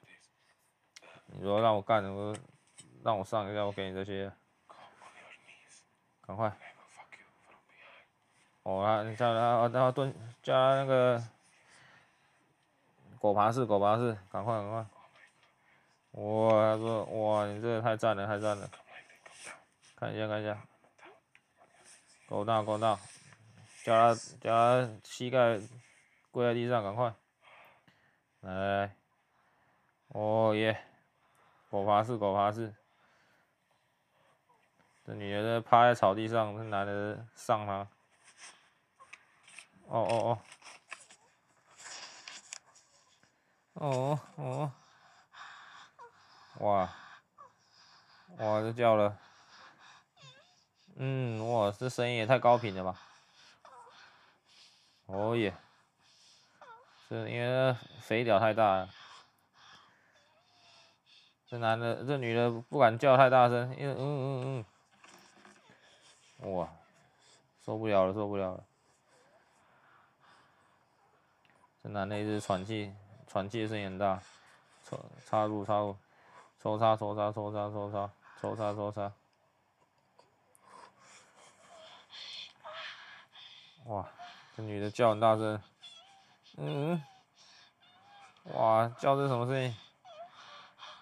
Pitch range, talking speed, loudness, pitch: 105-120 Hz, 140 characters per minute, -32 LUFS, 110 Hz